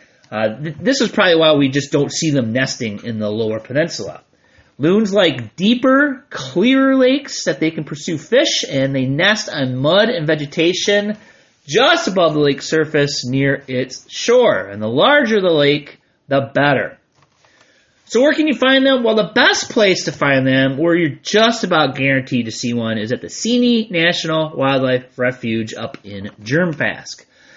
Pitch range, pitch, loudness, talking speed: 135-215 Hz, 155 Hz, -16 LUFS, 170 wpm